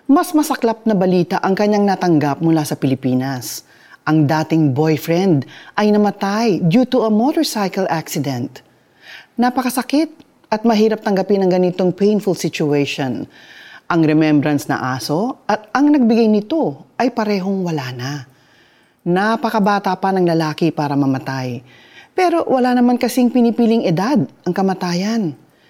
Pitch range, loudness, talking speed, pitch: 155-230 Hz, -17 LUFS, 125 wpm, 190 Hz